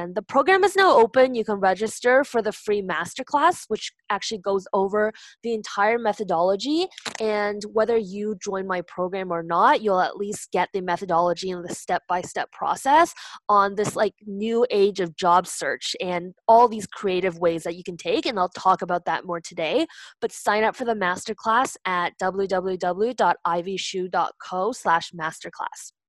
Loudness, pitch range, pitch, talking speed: -23 LUFS, 180-220 Hz, 200 Hz, 160 wpm